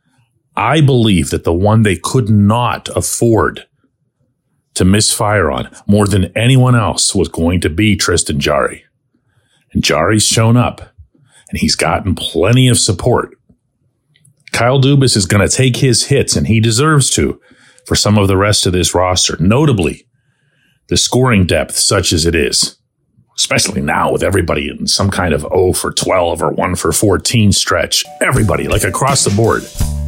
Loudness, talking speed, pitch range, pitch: -12 LUFS, 160 wpm, 95-125 Hz, 105 Hz